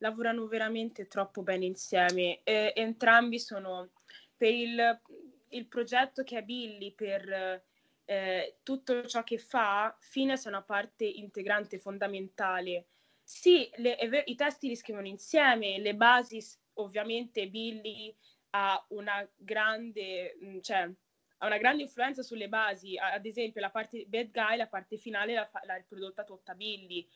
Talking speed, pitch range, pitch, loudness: 135 wpm, 195-235 Hz, 215 Hz, -32 LUFS